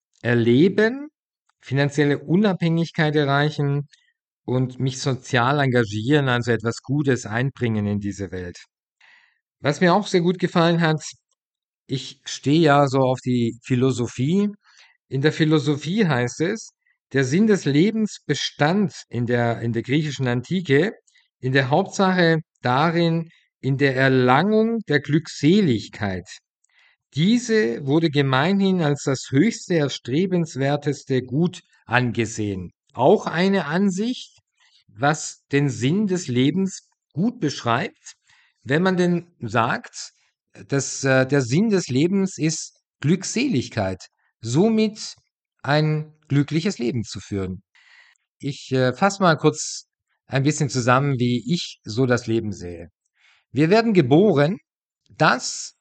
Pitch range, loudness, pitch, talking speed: 130-180 Hz, -21 LUFS, 145 Hz, 115 wpm